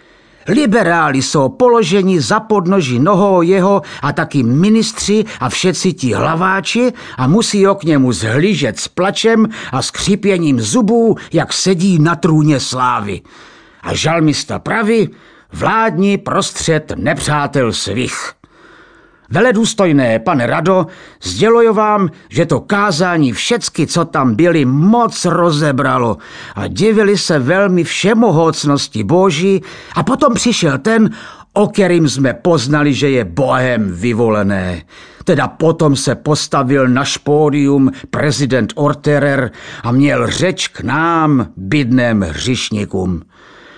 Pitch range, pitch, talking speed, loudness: 135-195 Hz, 160 Hz, 115 wpm, -13 LUFS